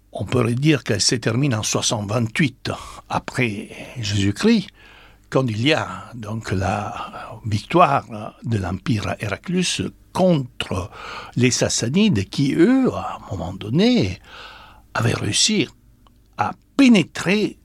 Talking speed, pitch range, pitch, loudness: 110 wpm, 105-155 Hz, 120 Hz, -20 LUFS